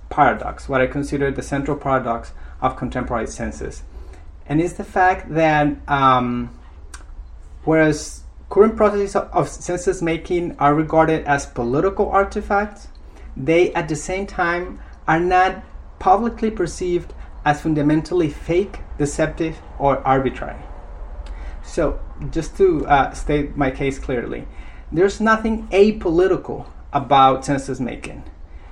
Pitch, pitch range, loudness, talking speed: 150 Hz, 125-180 Hz, -19 LUFS, 120 wpm